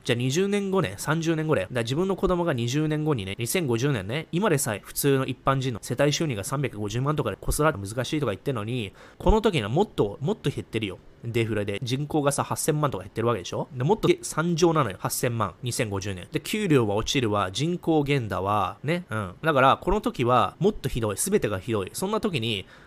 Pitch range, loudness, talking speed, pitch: 115-155 Hz, -26 LUFS, 375 characters per minute, 135 Hz